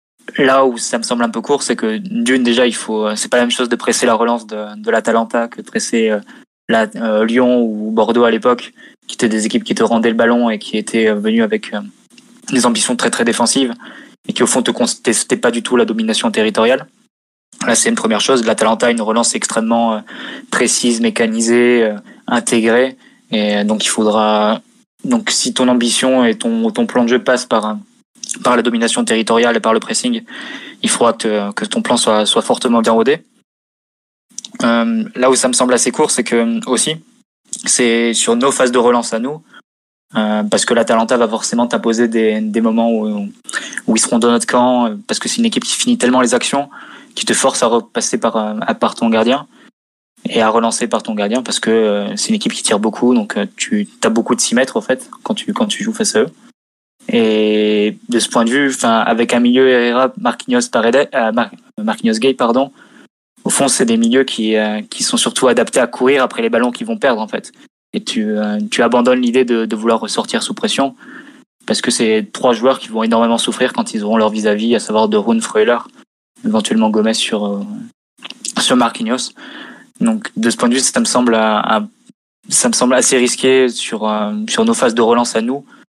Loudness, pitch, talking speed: -14 LUFS, 120 Hz, 215 wpm